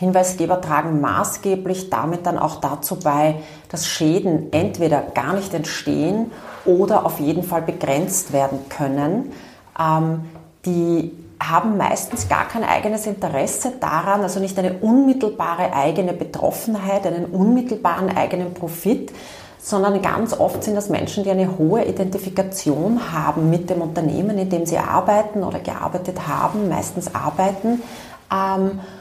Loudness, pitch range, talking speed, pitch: -20 LUFS, 160-195 Hz, 130 wpm, 180 Hz